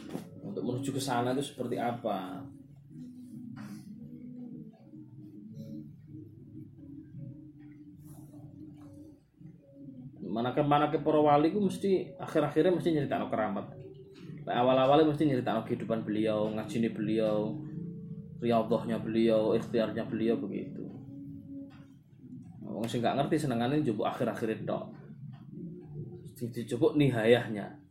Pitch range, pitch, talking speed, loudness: 120-155 Hz, 145 Hz, 90 wpm, -30 LUFS